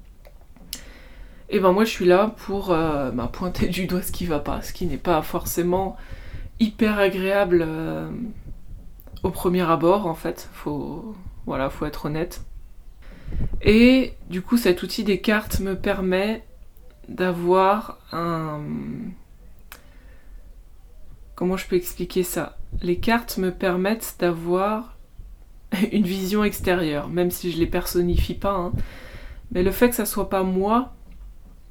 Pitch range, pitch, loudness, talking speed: 165-200 Hz, 185 Hz, -23 LUFS, 145 wpm